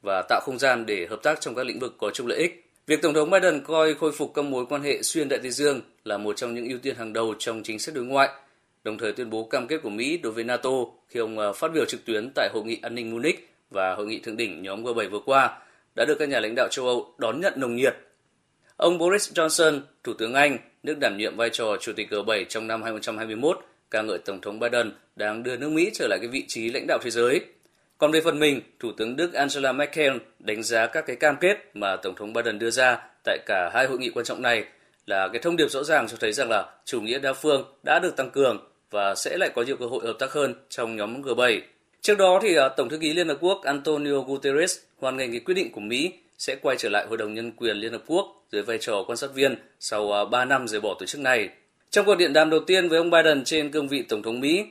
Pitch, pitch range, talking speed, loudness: 140 Hz, 115-165 Hz, 265 wpm, -25 LUFS